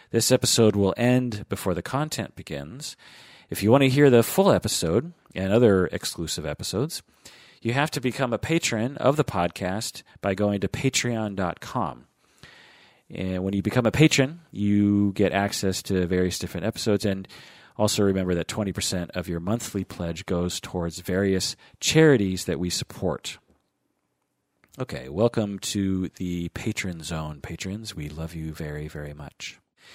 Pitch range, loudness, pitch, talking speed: 90-115 Hz, -25 LUFS, 100 Hz, 150 wpm